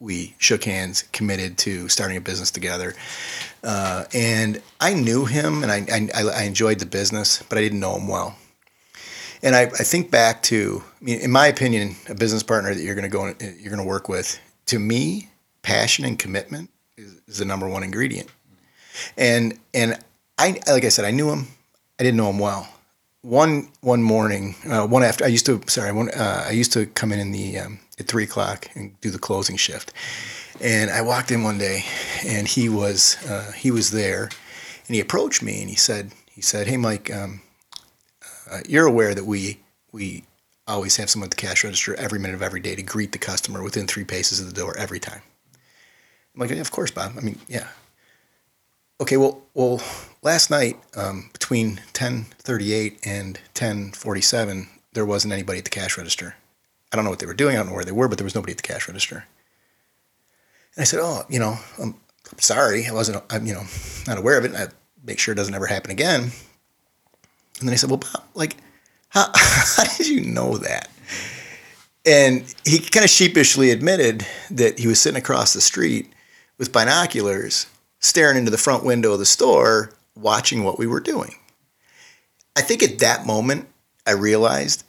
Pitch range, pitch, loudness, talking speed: 100-120 Hz, 110 Hz, -20 LUFS, 200 wpm